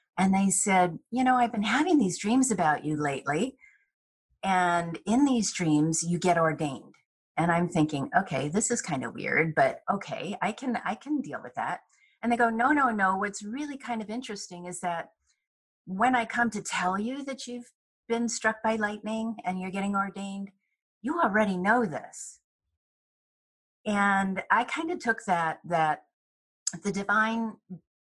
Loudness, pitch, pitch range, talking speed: -28 LUFS, 200 Hz, 175-240 Hz, 170 wpm